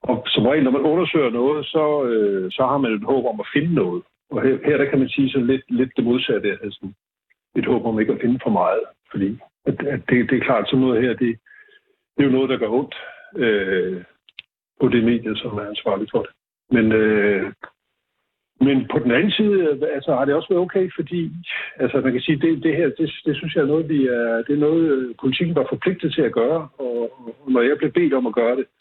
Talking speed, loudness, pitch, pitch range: 235 wpm, -20 LUFS, 135 Hz, 120-160 Hz